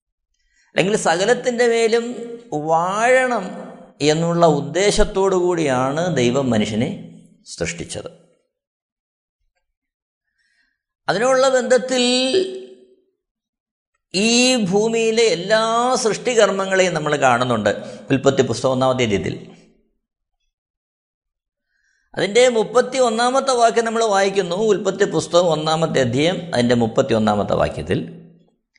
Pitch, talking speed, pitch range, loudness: 200 Hz, 75 wpm, 150-240 Hz, -18 LUFS